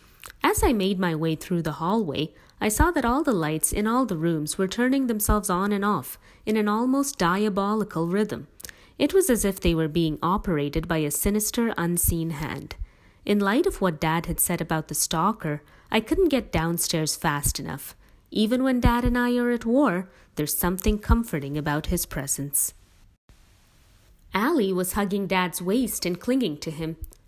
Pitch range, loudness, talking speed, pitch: 160-220 Hz, -24 LUFS, 180 wpm, 185 Hz